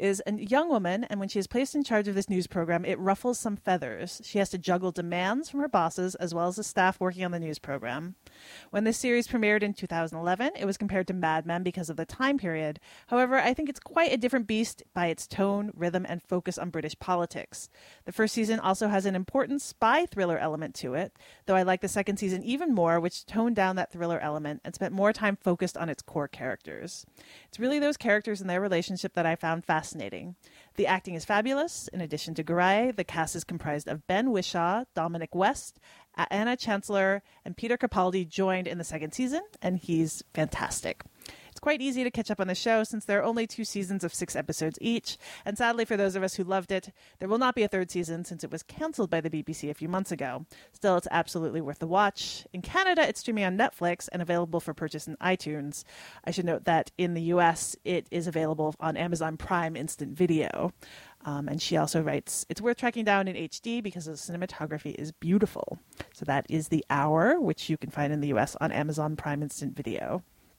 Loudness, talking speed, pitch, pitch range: -29 LUFS, 220 wpm, 185 Hz, 165-210 Hz